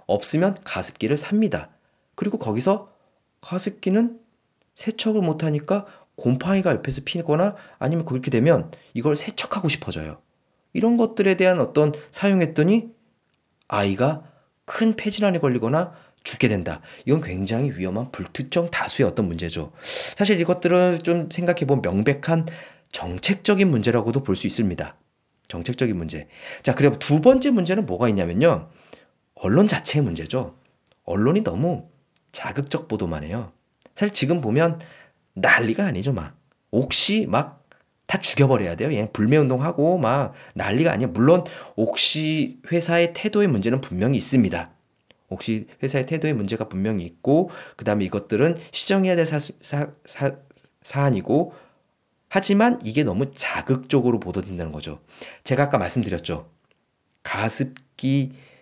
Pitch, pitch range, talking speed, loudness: 150 Hz, 115-180 Hz, 310 characters per minute, -22 LUFS